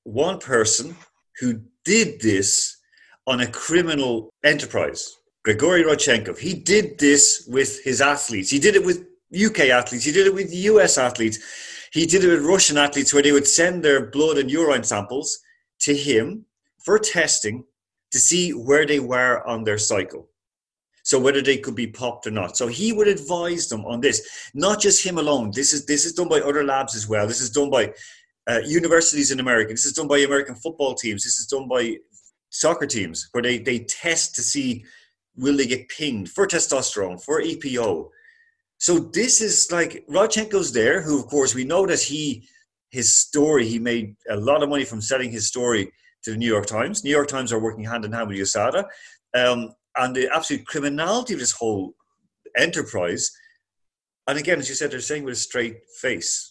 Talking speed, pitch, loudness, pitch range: 190 wpm, 145 Hz, -20 LUFS, 125-185 Hz